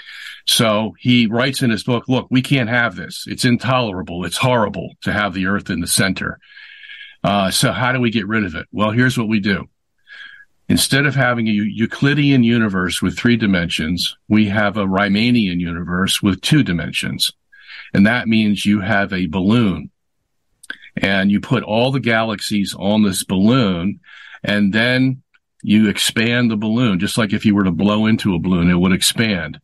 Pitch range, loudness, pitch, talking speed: 100-125 Hz, -17 LUFS, 110 Hz, 180 wpm